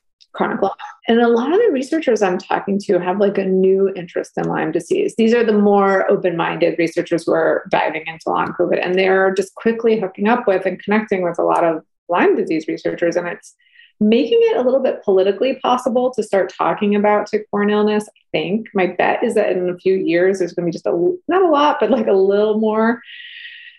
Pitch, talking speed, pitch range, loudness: 210 Hz, 215 wpm, 190-245 Hz, -17 LUFS